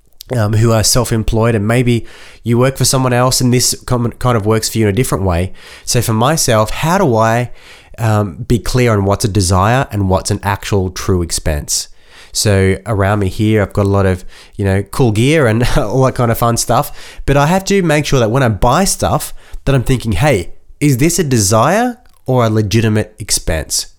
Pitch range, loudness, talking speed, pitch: 105-130 Hz, -13 LUFS, 210 wpm, 115 Hz